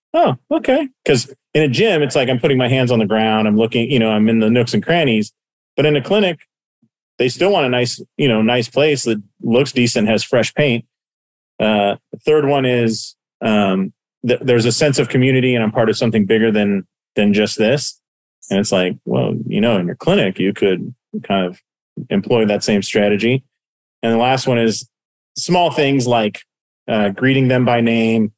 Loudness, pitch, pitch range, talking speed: -16 LUFS, 120 Hz, 110-135 Hz, 205 wpm